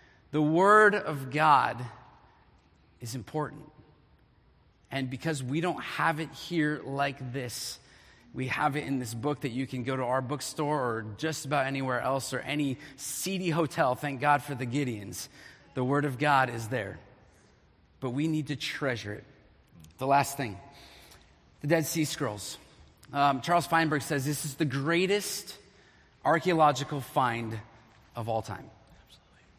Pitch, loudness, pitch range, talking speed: 135 Hz, -29 LUFS, 115-150 Hz, 150 wpm